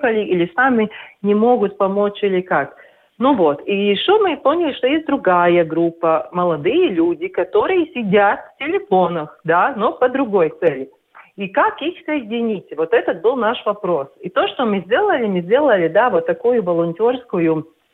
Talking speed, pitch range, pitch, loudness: 160 wpm, 185-300 Hz, 220 Hz, -17 LUFS